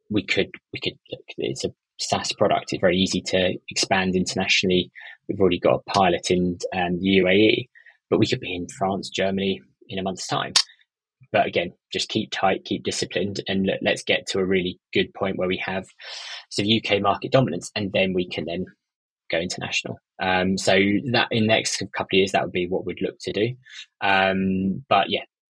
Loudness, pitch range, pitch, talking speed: -23 LUFS, 90-95 Hz, 95 Hz, 195 wpm